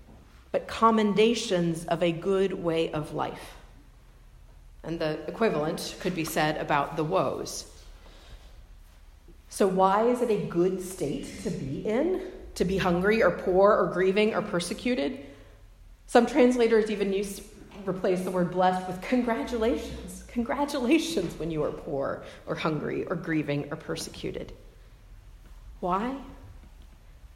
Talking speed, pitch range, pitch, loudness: 130 wpm, 155-215 Hz, 185 Hz, -27 LUFS